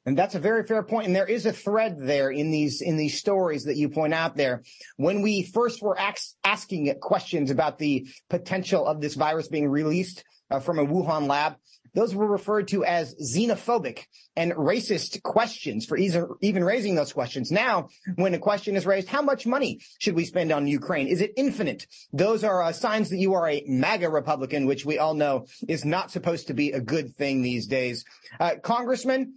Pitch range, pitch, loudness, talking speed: 145-205 Hz, 175 Hz, -26 LUFS, 205 wpm